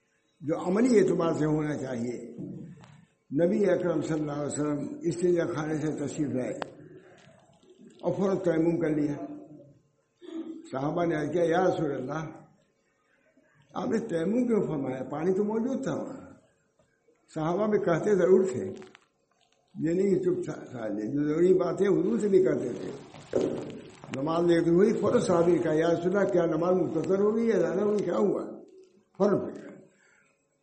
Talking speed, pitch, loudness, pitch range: 135 wpm, 170 Hz, -27 LUFS, 155-190 Hz